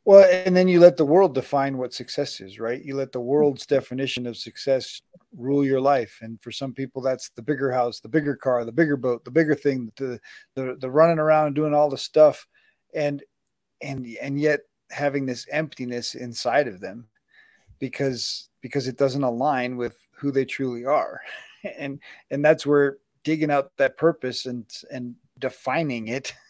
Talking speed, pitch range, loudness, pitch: 180 wpm, 125-150 Hz, -23 LUFS, 135 Hz